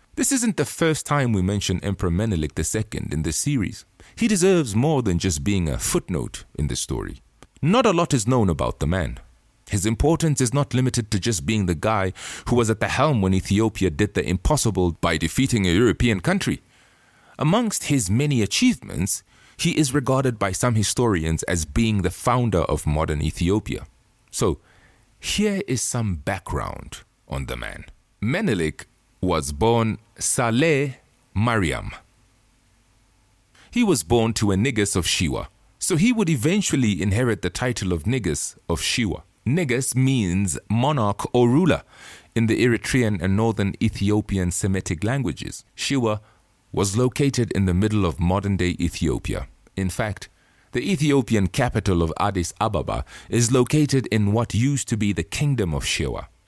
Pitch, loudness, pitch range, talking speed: 110 Hz, -22 LUFS, 95-130 Hz, 155 wpm